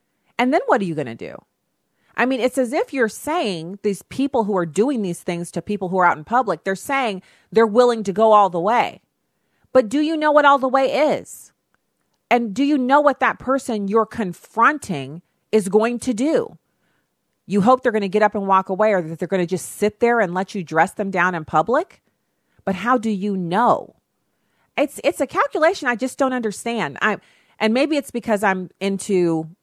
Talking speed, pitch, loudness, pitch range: 215 wpm, 220 Hz, -19 LUFS, 190-260 Hz